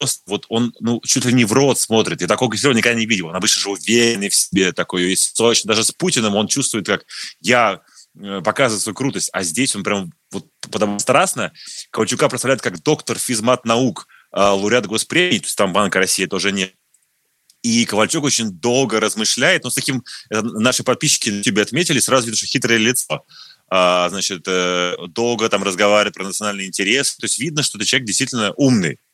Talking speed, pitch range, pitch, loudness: 185 wpm, 100-125 Hz, 115 Hz, -17 LUFS